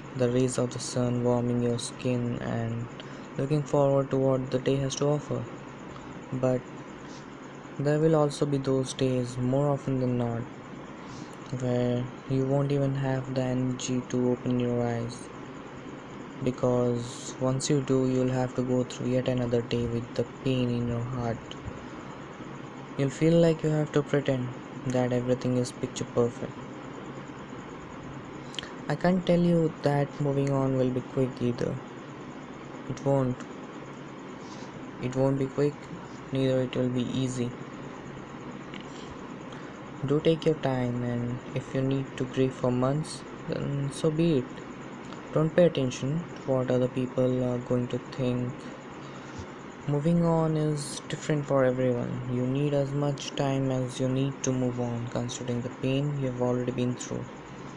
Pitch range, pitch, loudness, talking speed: 125-140 Hz, 130 Hz, -28 LUFS, 150 wpm